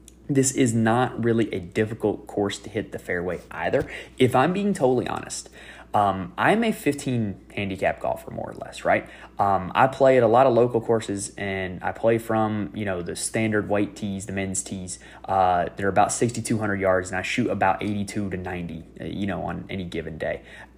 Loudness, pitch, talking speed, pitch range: -24 LUFS, 105 Hz, 195 wpm, 95-115 Hz